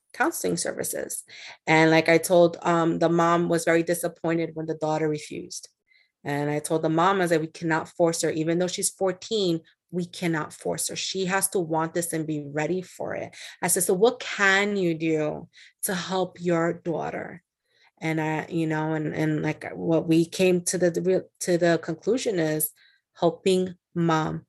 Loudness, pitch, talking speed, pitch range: -25 LUFS, 165 Hz, 180 wpm, 160-180 Hz